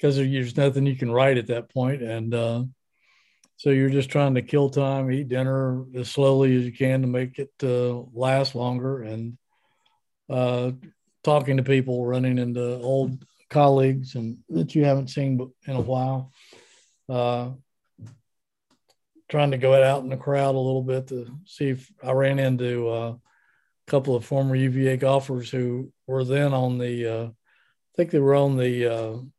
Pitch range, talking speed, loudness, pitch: 125-135 Hz, 175 wpm, -24 LUFS, 130 Hz